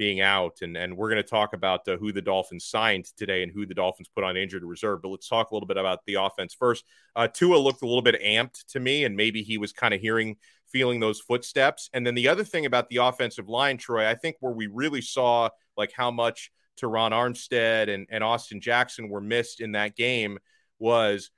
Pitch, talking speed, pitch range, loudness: 115 Hz, 235 wpm, 100-120 Hz, -26 LUFS